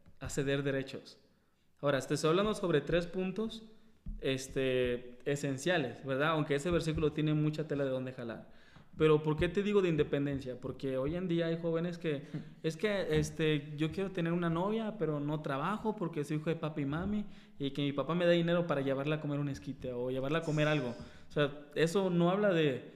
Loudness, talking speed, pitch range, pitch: -34 LUFS, 200 wpm, 140-170 Hz, 155 Hz